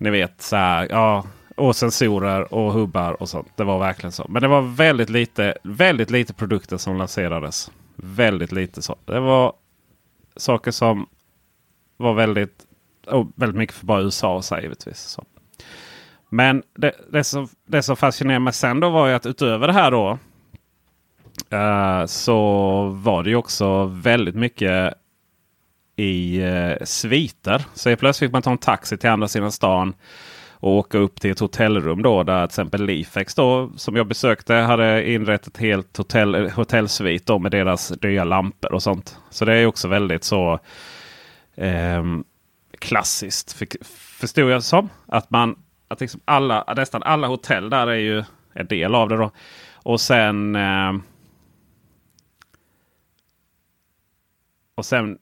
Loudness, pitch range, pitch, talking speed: -20 LUFS, 95-120 Hz, 105 Hz, 155 wpm